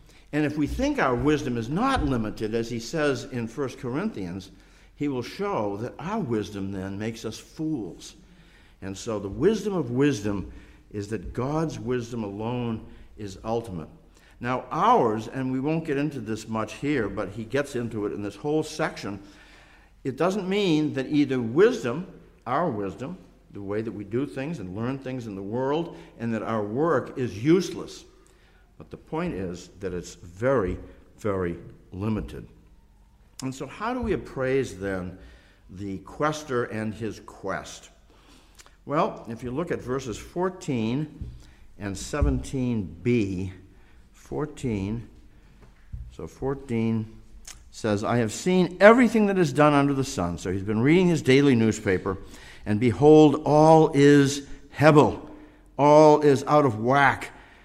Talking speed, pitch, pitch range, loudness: 150 wpm, 120 Hz, 100-145 Hz, -25 LUFS